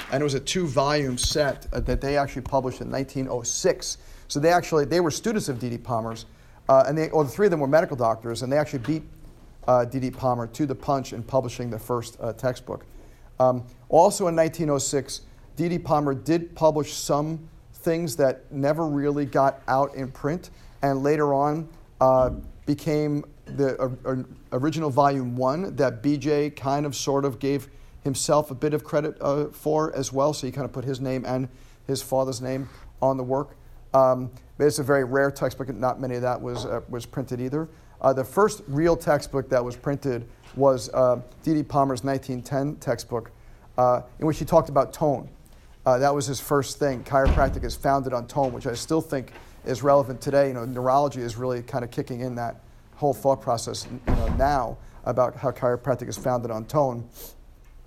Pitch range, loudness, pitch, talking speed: 125-145 Hz, -25 LUFS, 135 Hz, 190 wpm